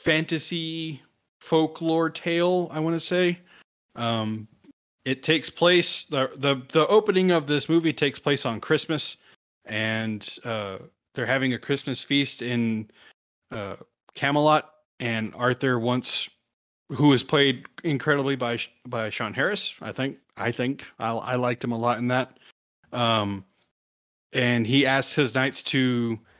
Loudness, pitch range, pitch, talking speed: -24 LUFS, 120-155 Hz, 135 Hz, 140 wpm